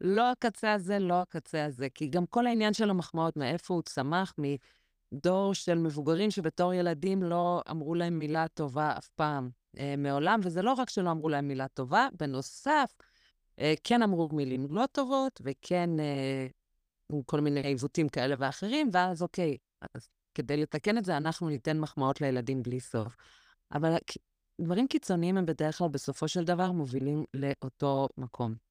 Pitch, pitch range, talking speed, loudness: 160 Hz, 140-180 Hz, 160 wpm, -31 LUFS